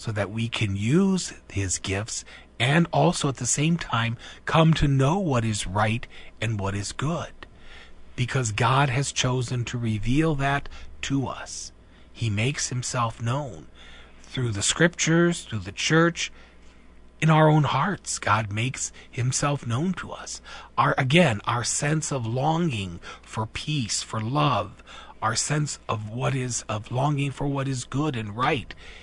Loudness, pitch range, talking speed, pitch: -25 LUFS, 105-145 Hz, 155 wpm, 125 Hz